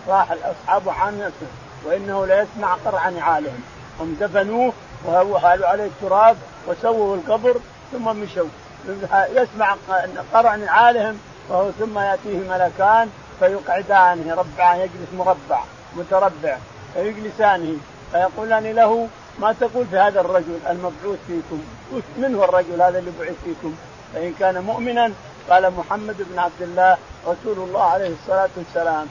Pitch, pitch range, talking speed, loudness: 190 Hz, 175-215 Hz, 120 wpm, -19 LUFS